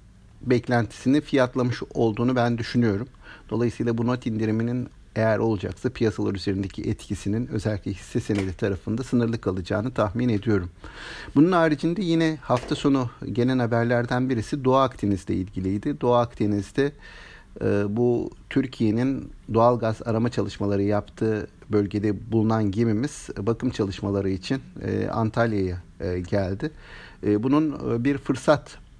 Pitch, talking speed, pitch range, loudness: 115 Hz, 110 wpm, 100-125 Hz, -25 LUFS